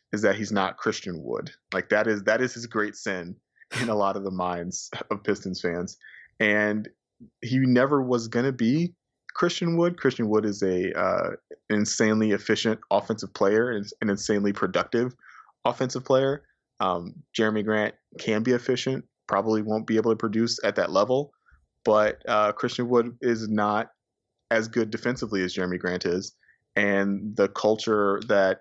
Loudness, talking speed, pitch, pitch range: -26 LUFS, 165 wpm, 110 Hz, 105-120 Hz